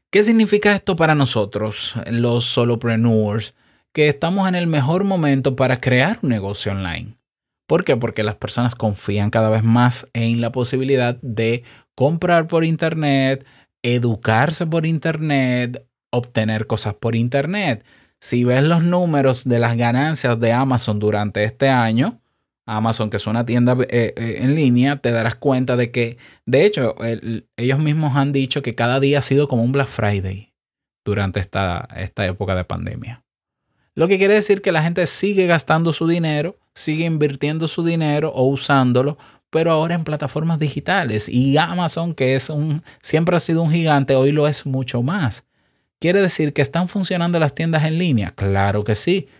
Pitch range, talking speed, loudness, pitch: 115-155 Hz, 165 wpm, -18 LUFS, 130 Hz